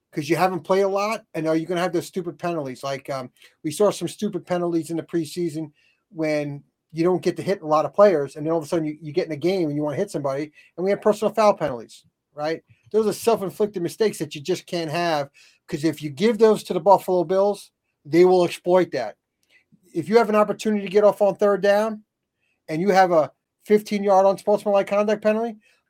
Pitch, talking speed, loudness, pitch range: 180 Hz, 245 wpm, -22 LUFS, 160-205 Hz